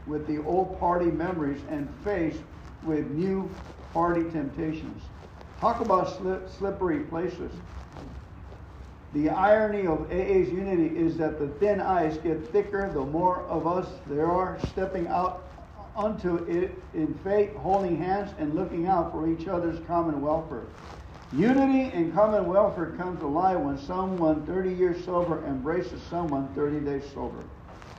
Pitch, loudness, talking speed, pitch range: 170 Hz, -27 LUFS, 145 wpm, 150-185 Hz